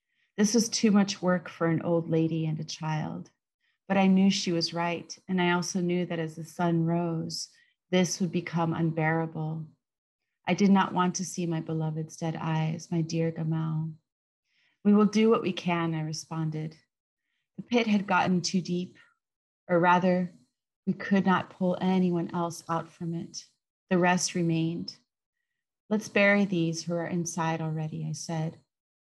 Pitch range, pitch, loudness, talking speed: 160-185 Hz, 170 Hz, -28 LUFS, 165 wpm